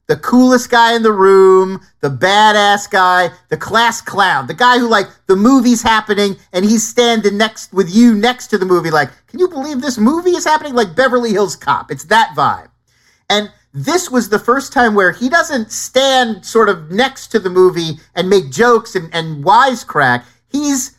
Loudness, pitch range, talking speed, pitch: -12 LUFS, 190-250 Hz, 190 wpm, 220 Hz